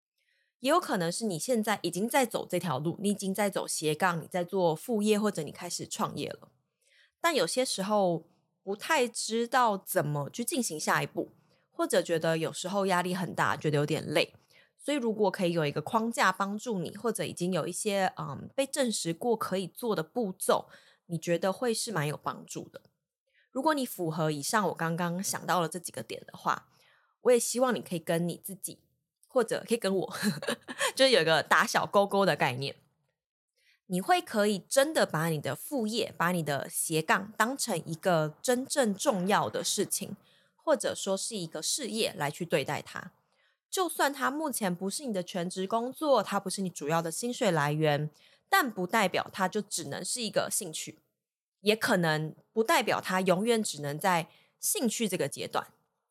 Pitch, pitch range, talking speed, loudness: 190 Hz, 165-230 Hz, 270 characters per minute, -30 LUFS